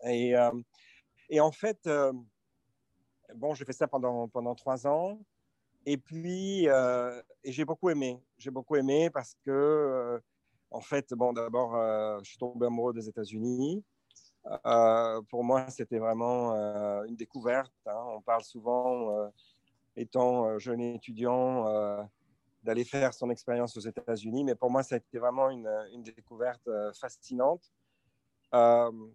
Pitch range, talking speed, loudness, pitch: 115-135 Hz, 150 wpm, -31 LUFS, 120 Hz